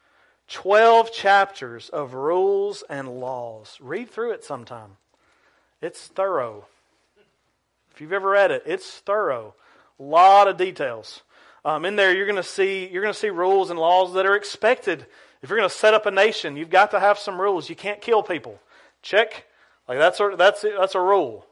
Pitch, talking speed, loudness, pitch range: 200 Hz, 185 wpm, -20 LUFS, 180-215 Hz